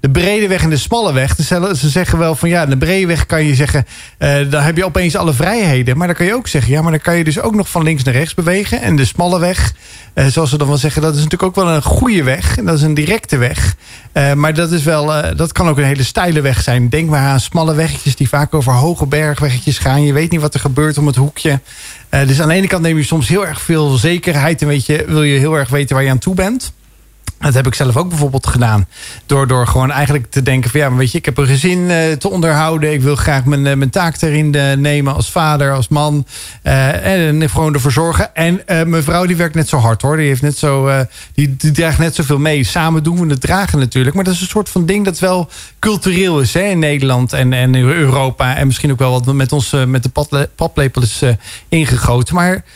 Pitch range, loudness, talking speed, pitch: 135-165 Hz, -13 LUFS, 265 wpm, 150 Hz